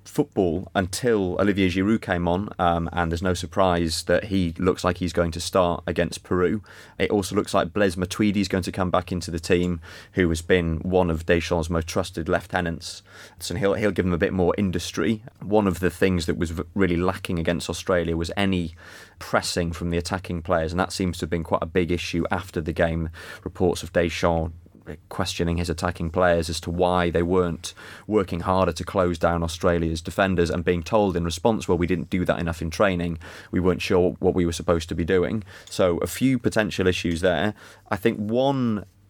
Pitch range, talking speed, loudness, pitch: 85-95 Hz, 205 wpm, -24 LUFS, 90 Hz